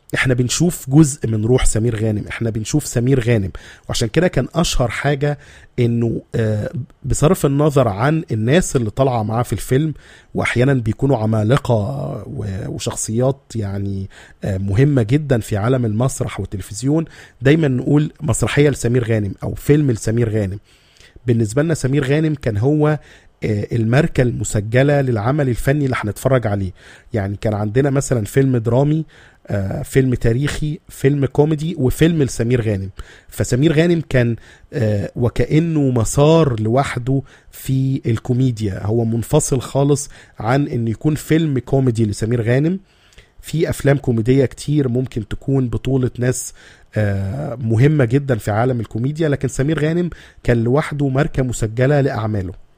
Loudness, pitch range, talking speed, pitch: -18 LUFS, 110-140 Hz, 125 wpm, 125 Hz